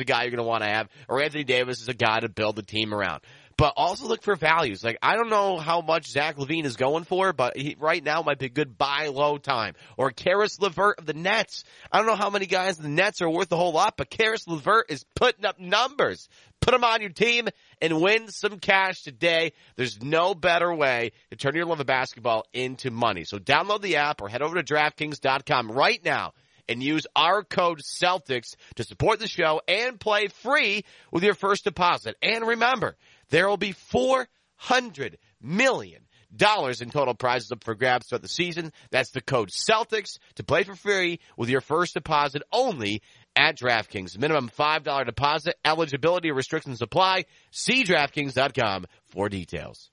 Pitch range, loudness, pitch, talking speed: 125-190 Hz, -24 LUFS, 150 Hz, 195 wpm